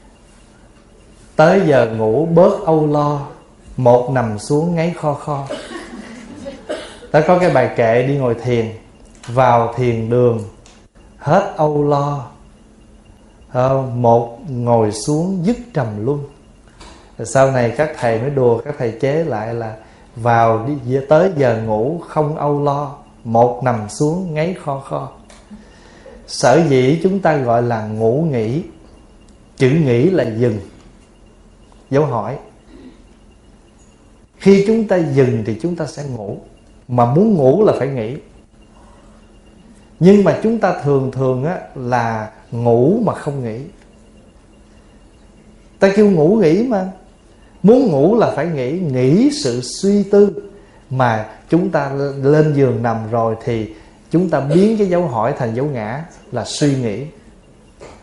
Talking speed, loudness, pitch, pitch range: 135 wpm, -16 LUFS, 135 Hz, 115-165 Hz